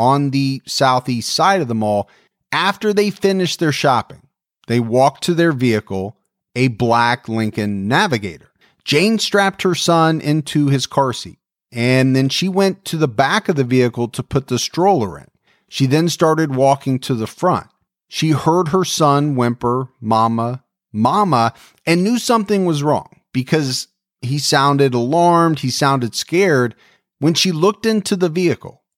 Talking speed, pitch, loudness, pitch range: 155 wpm, 140 Hz, -16 LUFS, 125-175 Hz